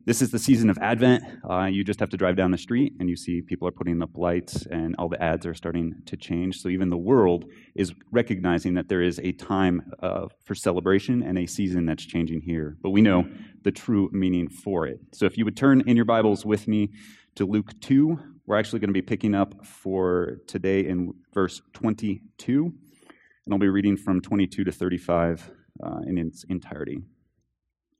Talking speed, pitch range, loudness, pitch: 205 wpm, 90-105 Hz, -25 LUFS, 95 Hz